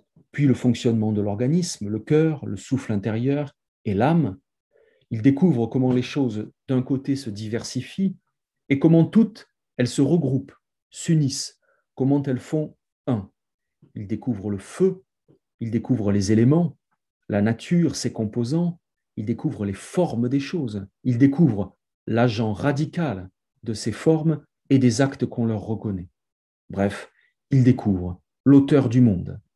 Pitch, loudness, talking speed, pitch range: 130 Hz, -23 LUFS, 140 wpm, 110-150 Hz